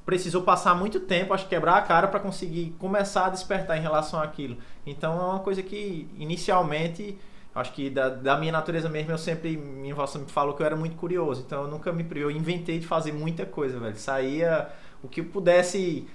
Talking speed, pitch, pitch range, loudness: 205 wpm, 165 Hz, 145-180 Hz, -27 LUFS